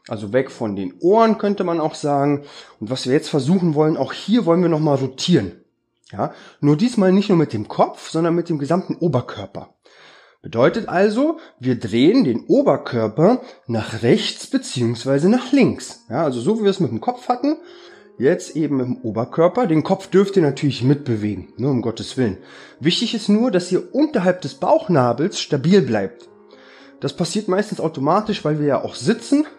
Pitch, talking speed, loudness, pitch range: 165 Hz, 185 wpm, -19 LUFS, 135-205 Hz